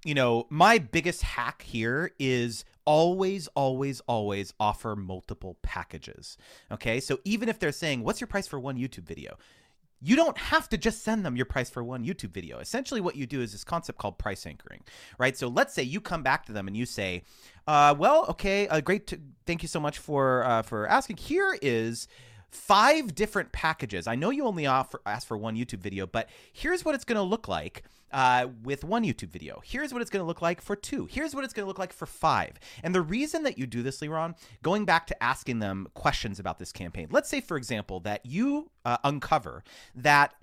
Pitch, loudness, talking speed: 145 Hz, -28 LUFS, 220 wpm